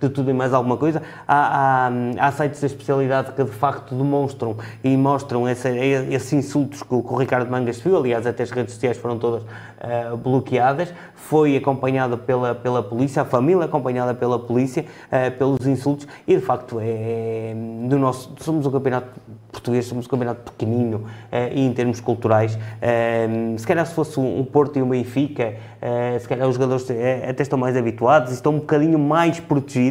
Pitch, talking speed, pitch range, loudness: 130 Hz, 185 wpm, 120-140 Hz, -21 LUFS